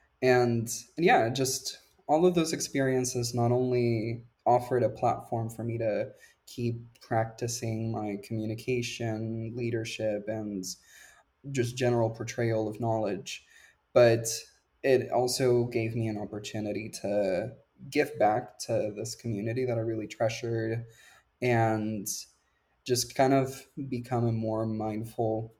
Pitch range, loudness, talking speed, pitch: 110-125 Hz, -30 LUFS, 120 wpm, 115 Hz